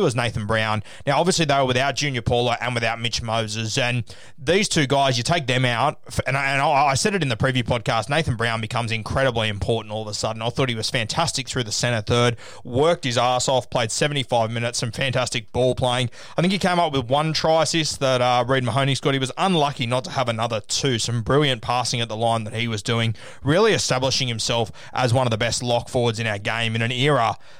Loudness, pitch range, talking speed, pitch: -21 LUFS, 115-135 Hz, 240 wpm, 125 Hz